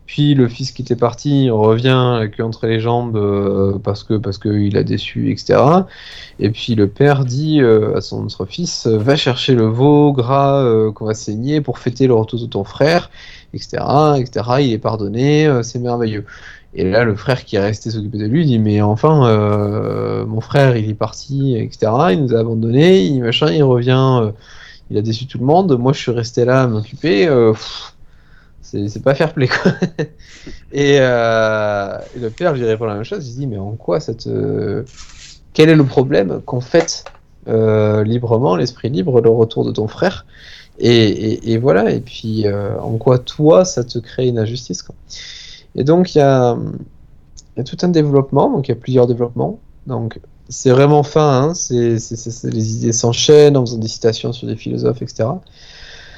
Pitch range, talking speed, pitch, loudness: 110-140 Hz, 200 wpm, 120 Hz, -15 LUFS